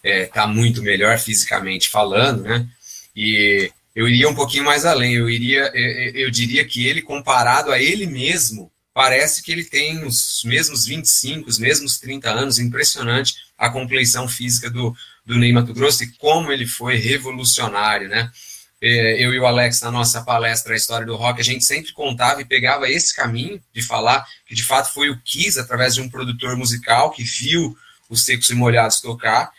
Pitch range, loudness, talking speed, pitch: 115-135 Hz, -17 LUFS, 180 wpm, 120 Hz